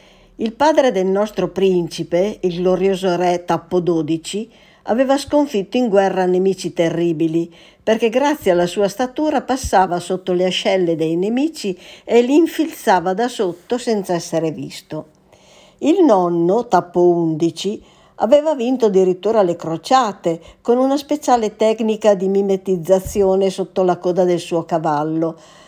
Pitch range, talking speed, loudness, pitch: 175-225 Hz, 130 wpm, -17 LUFS, 190 Hz